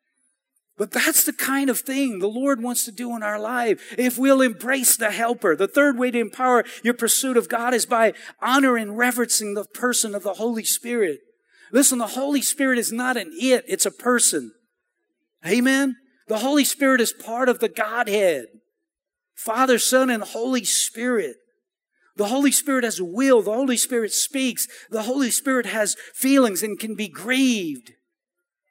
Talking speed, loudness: 175 wpm, -21 LUFS